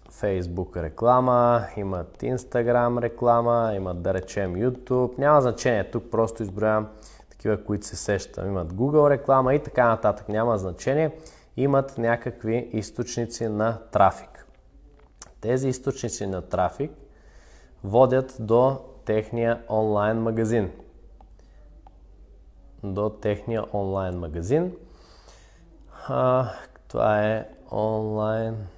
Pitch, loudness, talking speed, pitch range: 115 Hz, -24 LUFS, 100 wpm, 105-125 Hz